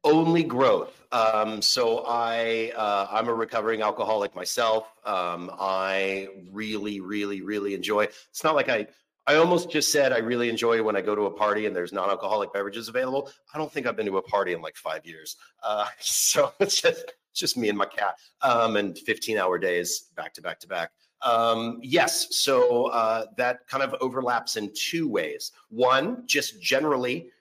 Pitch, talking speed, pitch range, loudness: 115 Hz, 180 wpm, 105-140 Hz, -25 LUFS